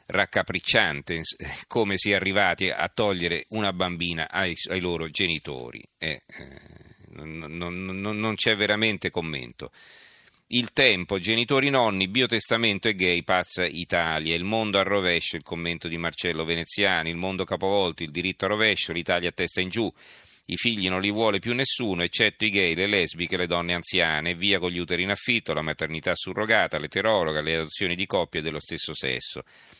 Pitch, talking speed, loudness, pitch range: 90 Hz, 170 wpm, -24 LUFS, 85-105 Hz